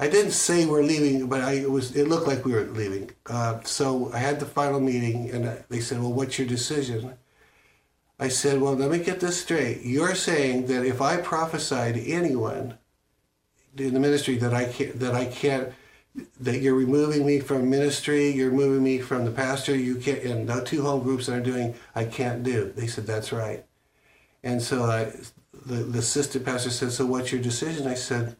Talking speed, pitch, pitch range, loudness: 205 wpm, 130 Hz, 120-140 Hz, -25 LUFS